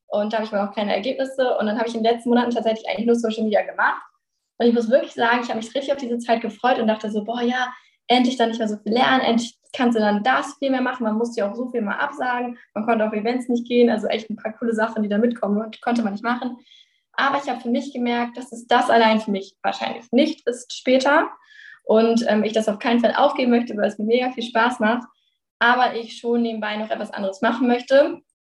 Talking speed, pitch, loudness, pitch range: 255 wpm, 235 Hz, -21 LUFS, 220-255 Hz